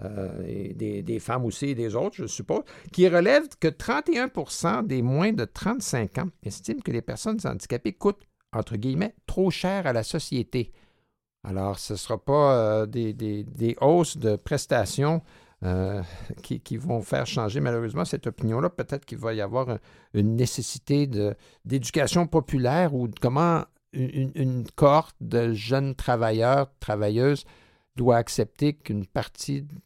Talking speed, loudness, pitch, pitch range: 160 wpm, -26 LUFS, 130 Hz, 110-160 Hz